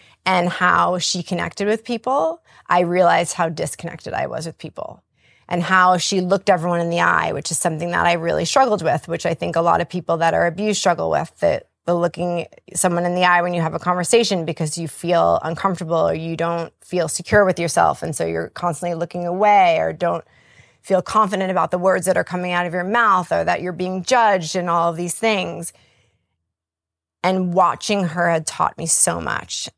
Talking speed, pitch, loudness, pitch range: 210 wpm, 175 Hz, -19 LUFS, 165-185 Hz